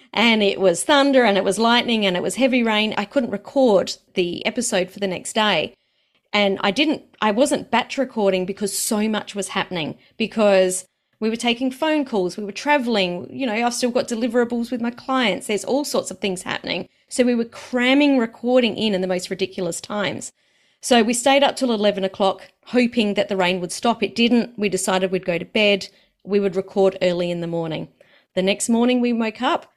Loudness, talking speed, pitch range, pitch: -20 LUFS, 210 wpm, 195-245 Hz, 215 Hz